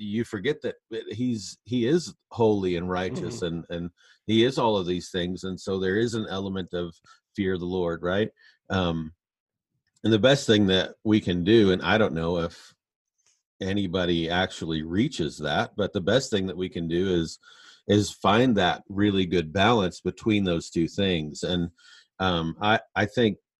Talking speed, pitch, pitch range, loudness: 180 wpm, 95 Hz, 90-110 Hz, -25 LUFS